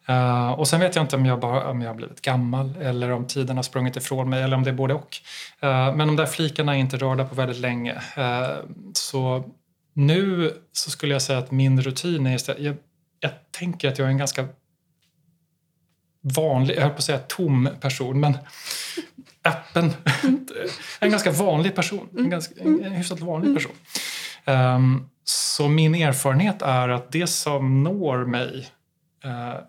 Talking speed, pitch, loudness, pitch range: 175 wpm, 145 Hz, -23 LUFS, 130-165 Hz